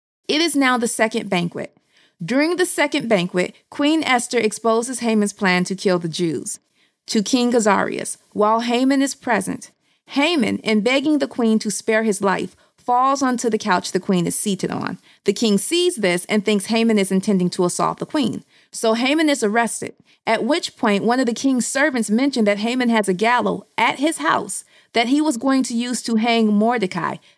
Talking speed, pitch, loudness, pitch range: 190 wpm, 230 Hz, -19 LUFS, 205-260 Hz